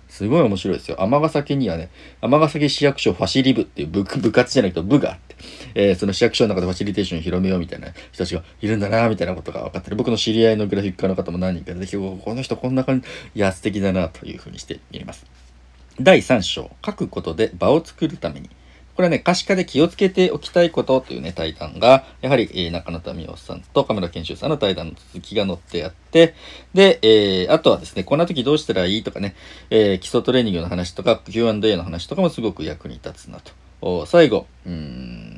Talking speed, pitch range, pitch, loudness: 455 characters per minute, 85-130 Hz, 100 Hz, -19 LUFS